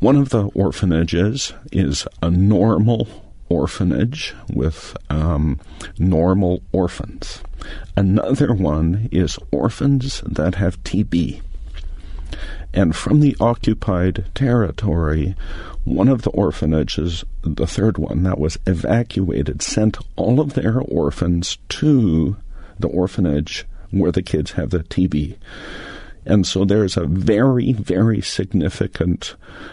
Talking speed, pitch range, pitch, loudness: 110 wpm, 80-110 Hz, 90 Hz, -19 LUFS